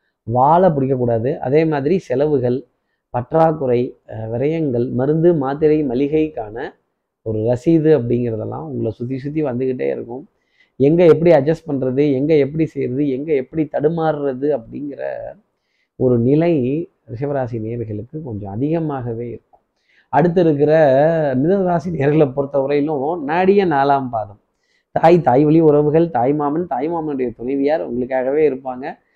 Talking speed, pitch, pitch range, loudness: 110 wpm, 145 Hz, 125-155 Hz, -17 LUFS